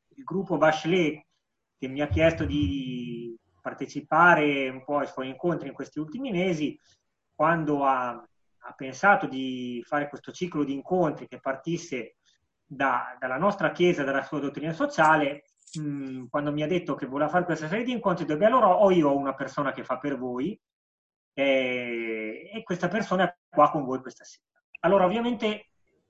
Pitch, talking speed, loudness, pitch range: 150 Hz, 170 wpm, -26 LUFS, 135-175 Hz